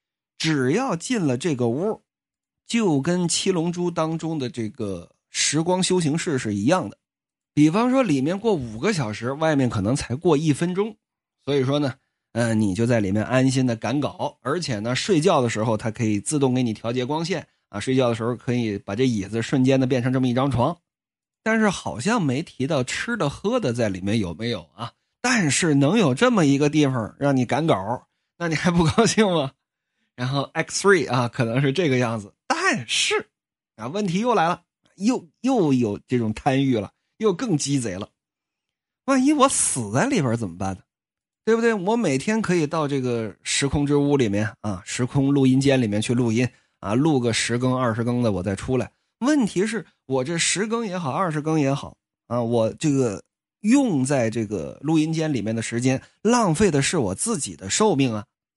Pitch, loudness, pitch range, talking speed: 135 Hz, -22 LUFS, 115-170 Hz, 275 characters per minute